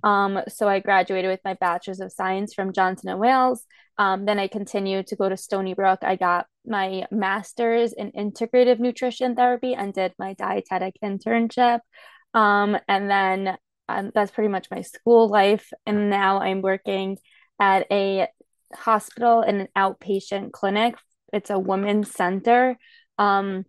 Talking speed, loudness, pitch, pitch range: 155 wpm, -22 LUFS, 200 Hz, 190-230 Hz